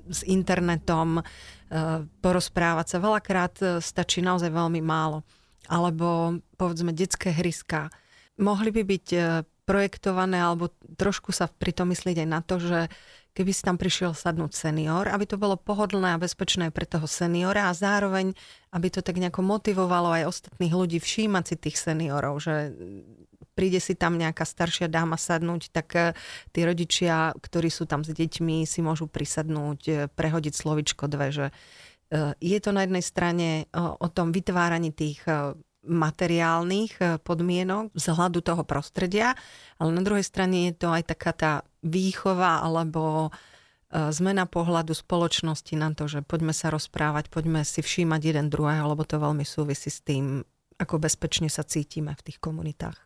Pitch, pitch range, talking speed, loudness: 170 Hz, 155-180 Hz, 150 wpm, -27 LUFS